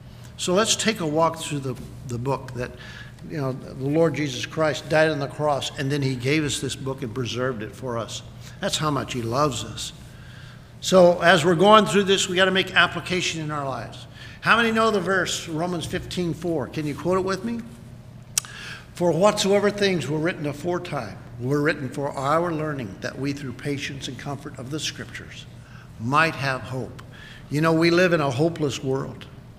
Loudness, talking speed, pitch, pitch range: -23 LUFS, 195 wpm, 145 Hz, 125-170 Hz